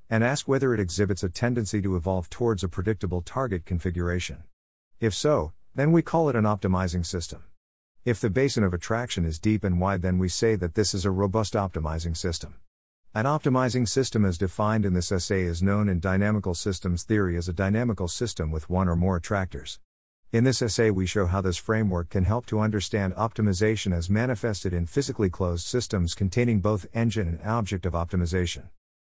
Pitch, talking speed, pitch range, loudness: 100 Hz, 190 wpm, 90-110 Hz, -26 LUFS